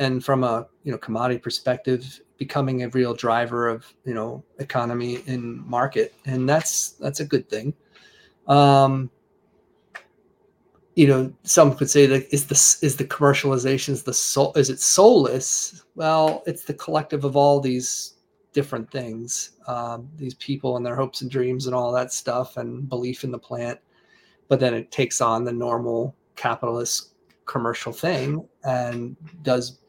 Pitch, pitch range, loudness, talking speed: 130 Hz, 120-140 Hz, -22 LUFS, 160 wpm